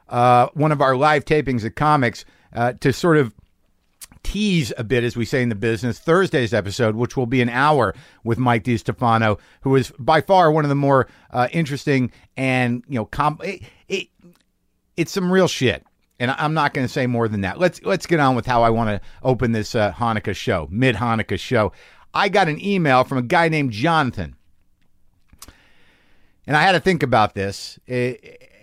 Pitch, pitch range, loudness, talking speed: 125 Hz, 115-150 Hz, -19 LUFS, 200 wpm